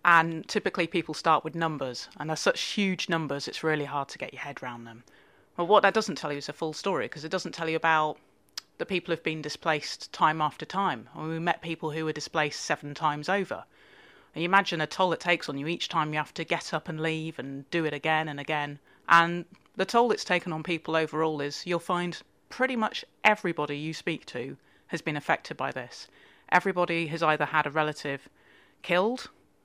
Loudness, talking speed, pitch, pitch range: -28 LUFS, 220 wpm, 160 Hz, 150-175 Hz